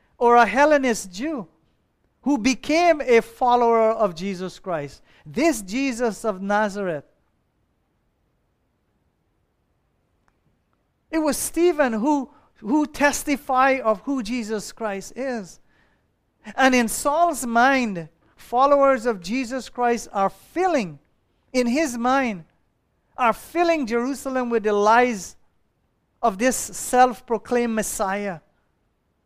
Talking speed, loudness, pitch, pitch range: 100 wpm, -21 LUFS, 245 Hz, 215-275 Hz